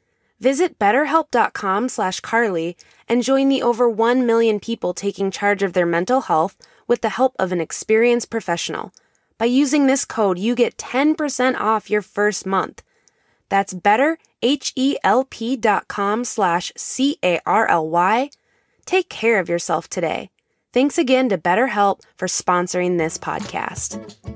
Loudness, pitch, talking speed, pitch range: -19 LUFS, 225 Hz, 130 wpm, 190-260 Hz